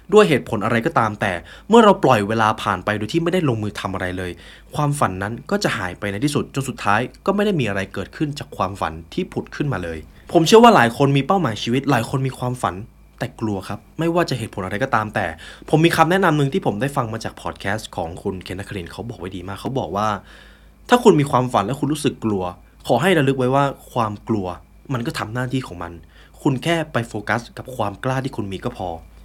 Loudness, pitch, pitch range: -20 LUFS, 115 Hz, 100-140 Hz